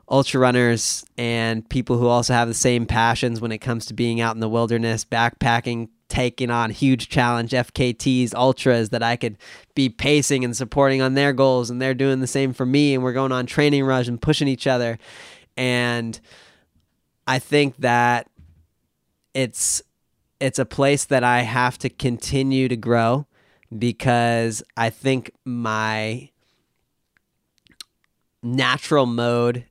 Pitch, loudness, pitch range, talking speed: 120 Hz, -20 LUFS, 115-130 Hz, 150 wpm